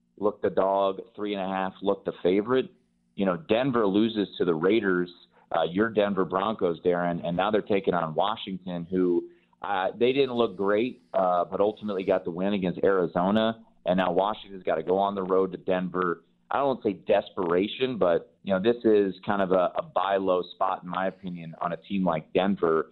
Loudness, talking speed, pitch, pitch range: -26 LUFS, 190 wpm, 95 Hz, 90-105 Hz